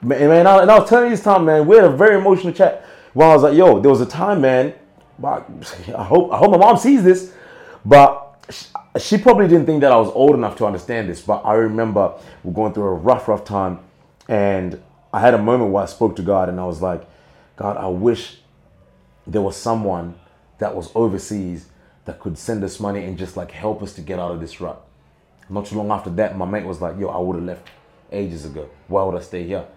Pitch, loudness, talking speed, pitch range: 105 Hz, -15 LUFS, 240 wpm, 95-145 Hz